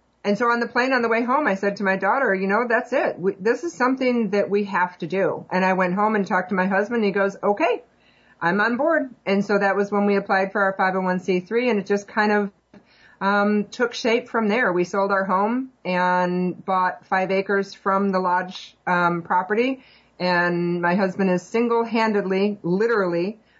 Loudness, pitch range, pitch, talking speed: -22 LUFS, 185-230 Hz, 200 Hz, 210 wpm